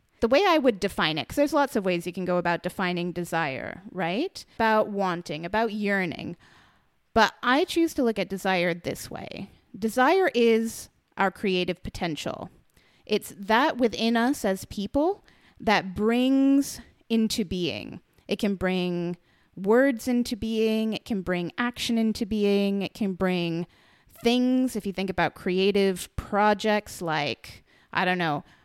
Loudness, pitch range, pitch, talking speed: -26 LUFS, 180-235 Hz, 205 Hz, 150 wpm